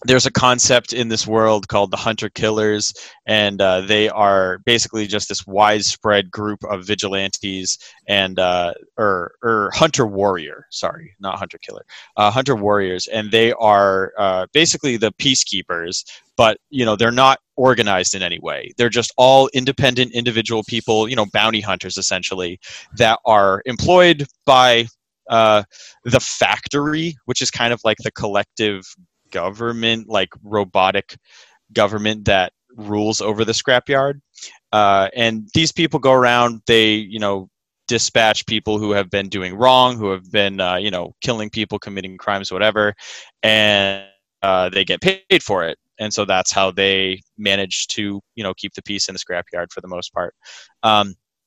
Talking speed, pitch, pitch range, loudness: 160 wpm, 105 Hz, 100-120 Hz, -17 LUFS